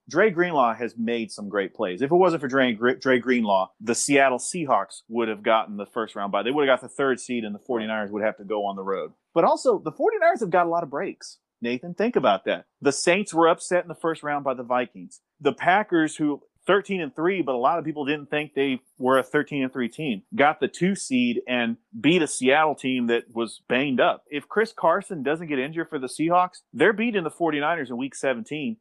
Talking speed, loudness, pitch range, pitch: 240 wpm, -24 LUFS, 120-170 Hz, 140 Hz